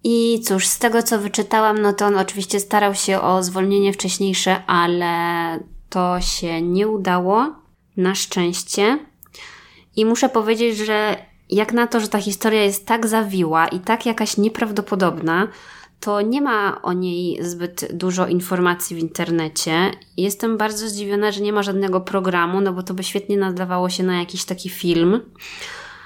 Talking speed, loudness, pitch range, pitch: 155 wpm, -19 LUFS, 180-215 Hz, 195 Hz